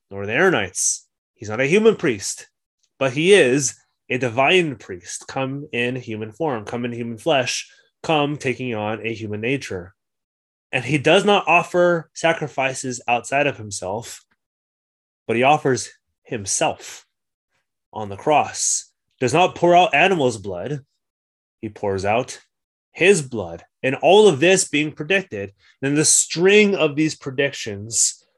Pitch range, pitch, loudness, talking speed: 110-155 Hz, 135 Hz, -19 LUFS, 140 wpm